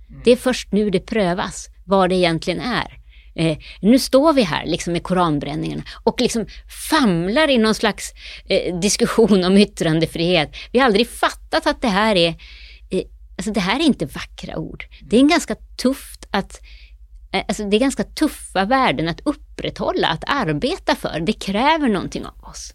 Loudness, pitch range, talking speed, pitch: -19 LUFS, 165-240 Hz, 175 wpm, 205 Hz